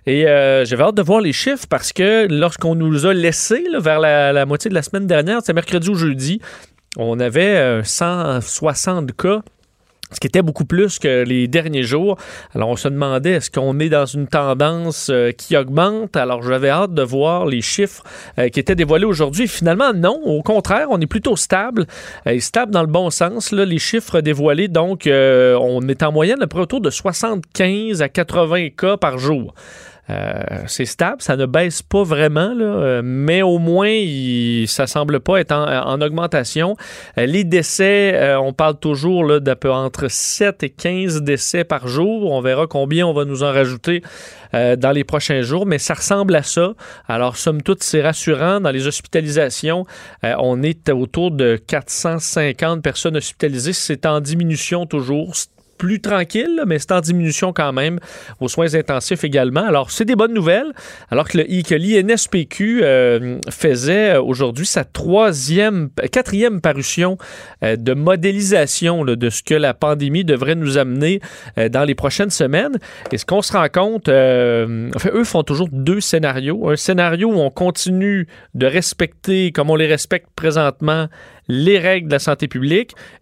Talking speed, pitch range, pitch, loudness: 180 wpm, 140-185 Hz, 160 Hz, -16 LUFS